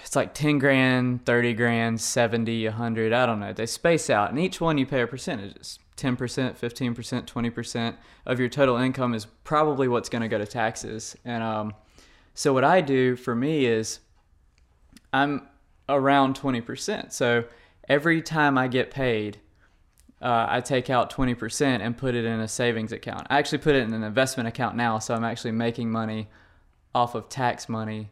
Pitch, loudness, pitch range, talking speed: 120 Hz, -25 LUFS, 110-130 Hz, 175 wpm